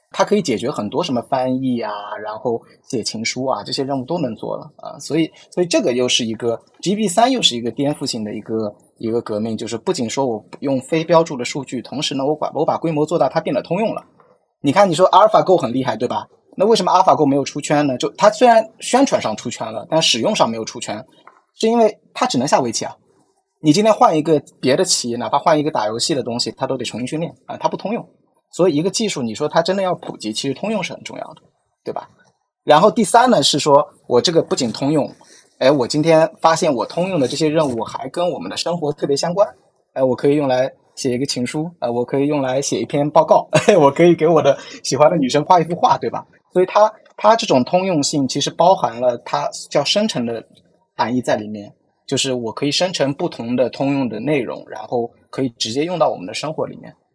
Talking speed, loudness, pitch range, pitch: 350 characters per minute, -18 LUFS, 125-175 Hz, 145 Hz